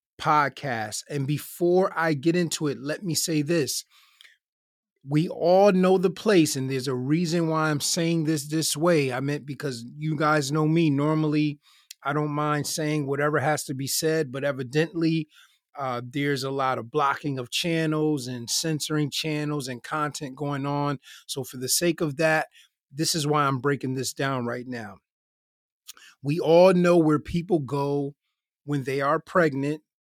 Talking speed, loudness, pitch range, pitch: 170 wpm, -25 LUFS, 140-160 Hz, 150 Hz